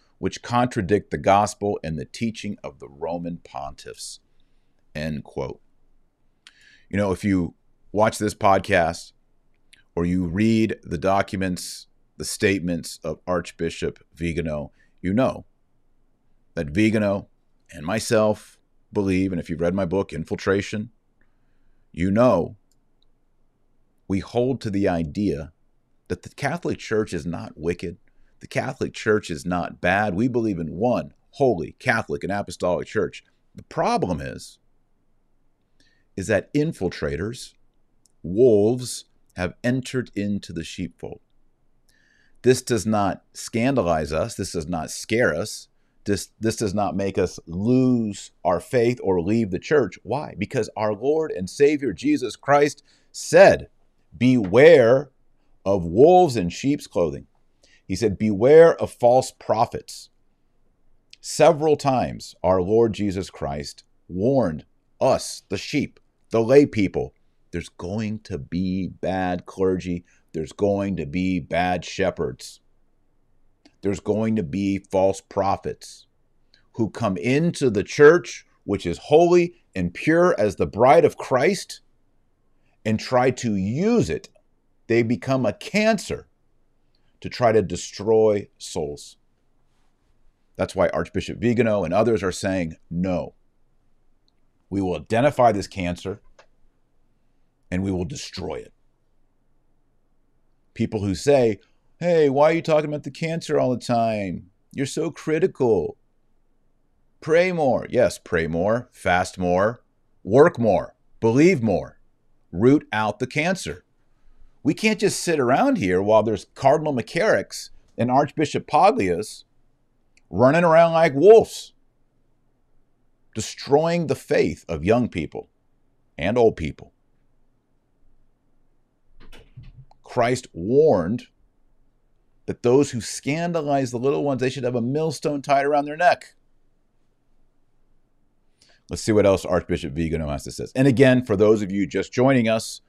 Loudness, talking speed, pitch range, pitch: -22 LUFS, 125 wpm, 95-130 Hz, 110 Hz